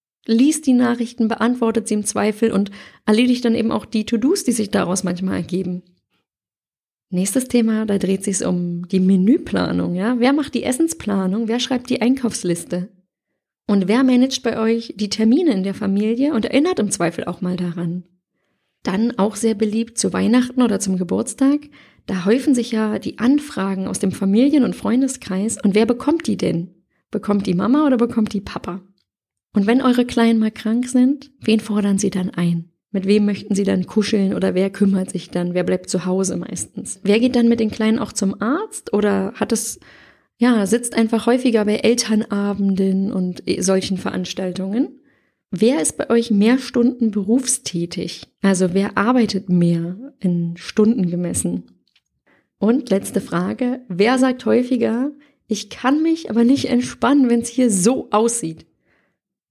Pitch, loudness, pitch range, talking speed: 215 Hz, -19 LUFS, 190-240 Hz, 165 wpm